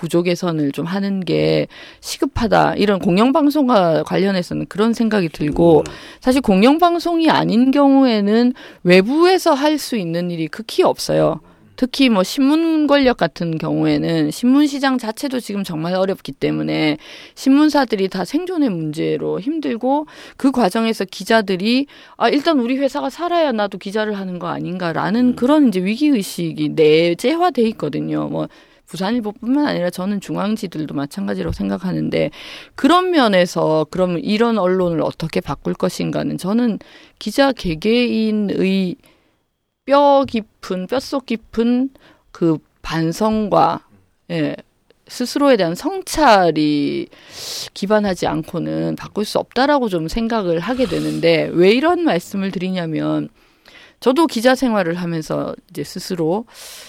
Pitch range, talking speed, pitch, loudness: 165-265 Hz, 295 characters per minute, 205 Hz, -17 LUFS